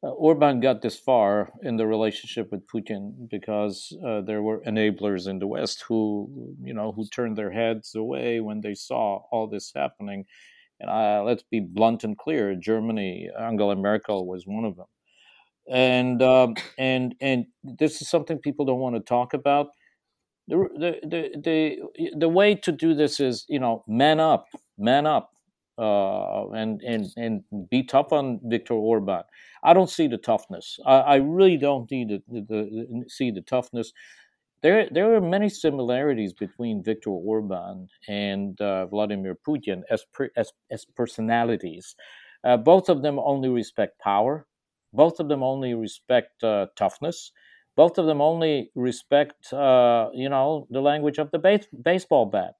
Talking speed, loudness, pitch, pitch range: 165 wpm, -24 LUFS, 120 Hz, 105-140 Hz